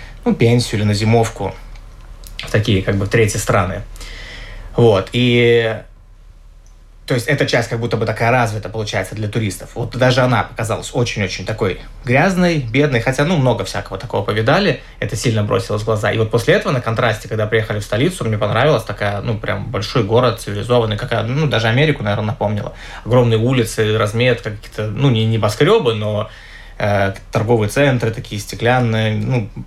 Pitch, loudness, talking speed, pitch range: 110 Hz, -17 LUFS, 165 wpm, 105-120 Hz